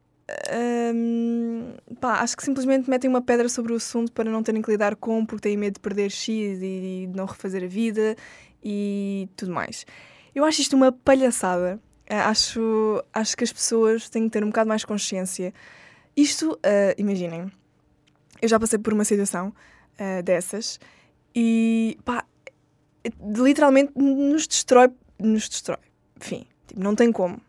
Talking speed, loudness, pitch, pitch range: 160 wpm, -23 LUFS, 220 Hz, 200-240 Hz